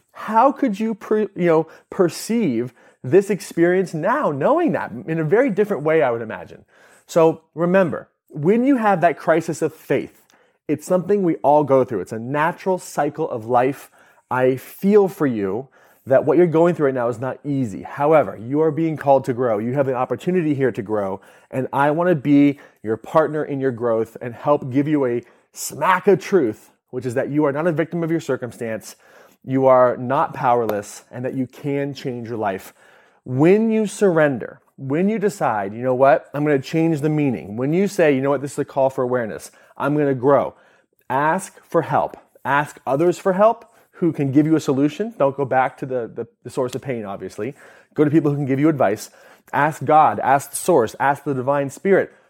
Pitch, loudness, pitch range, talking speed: 145 Hz, -19 LUFS, 130-165 Hz, 205 wpm